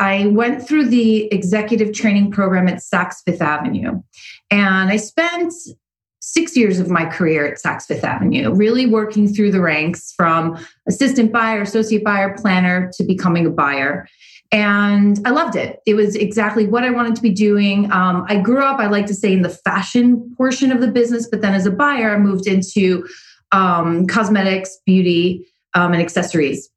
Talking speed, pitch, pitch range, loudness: 180 wpm, 205 Hz, 185-225 Hz, -16 LUFS